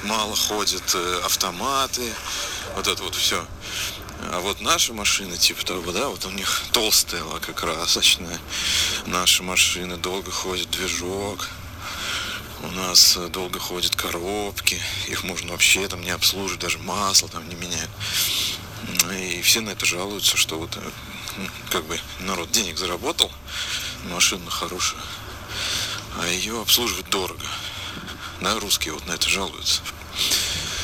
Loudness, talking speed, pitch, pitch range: -22 LUFS, 130 wpm, 95 Hz, 90-100 Hz